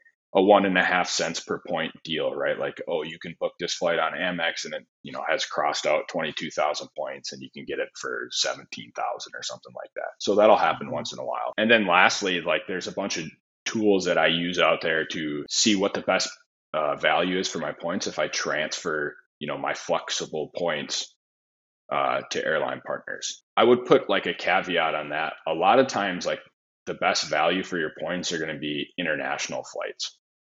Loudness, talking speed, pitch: -25 LUFS, 210 wpm, 95 Hz